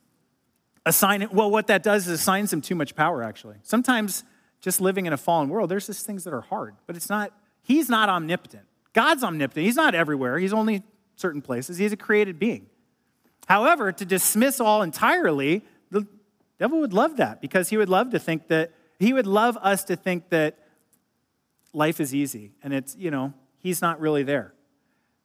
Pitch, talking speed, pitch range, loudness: 190 Hz, 190 wpm, 155-215 Hz, -23 LUFS